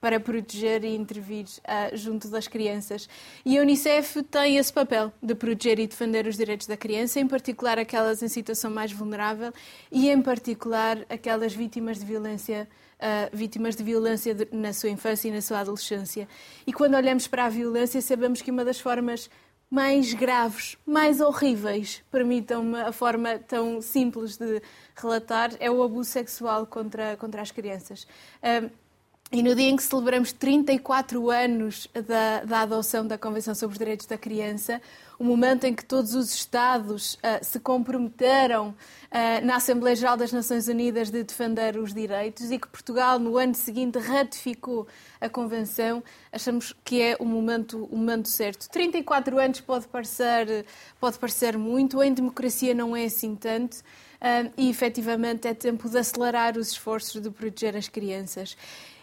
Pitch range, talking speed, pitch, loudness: 220-250 Hz, 165 wpm, 230 Hz, -26 LUFS